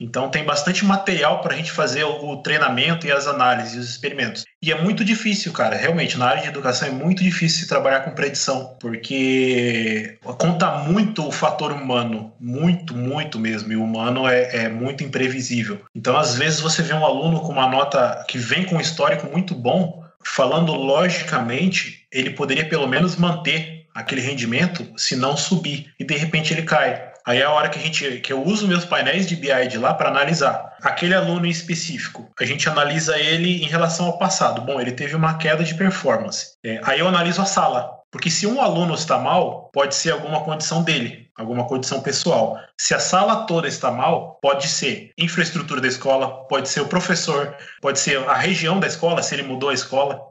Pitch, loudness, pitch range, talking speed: 150 Hz, -20 LUFS, 130-170 Hz, 195 wpm